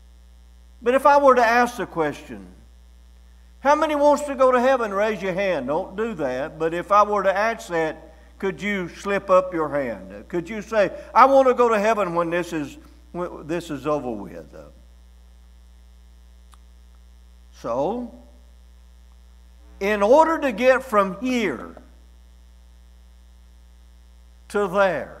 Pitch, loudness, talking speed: 155 Hz, -21 LUFS, 145 wpm